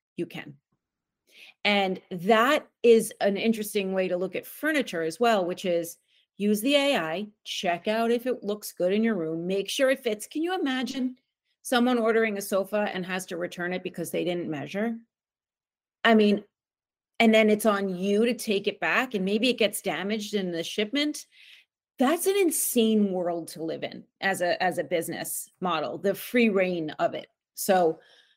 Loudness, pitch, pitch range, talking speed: -26 LUFS, 205 Hz, 180-230 Hz, 180 wpm